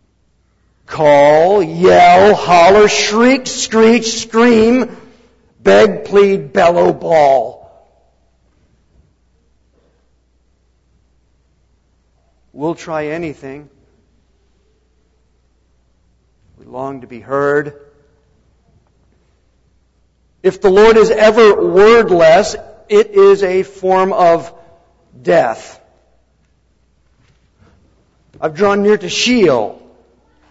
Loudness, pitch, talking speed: -11 LUFS, 145 Hz, 70 wpm